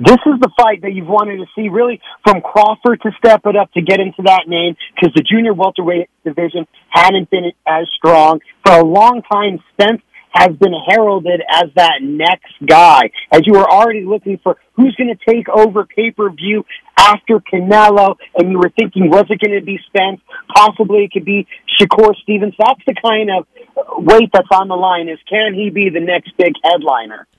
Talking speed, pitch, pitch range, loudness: 195 wpm, 200 Hz, 180-215 Hz, -11 LUFS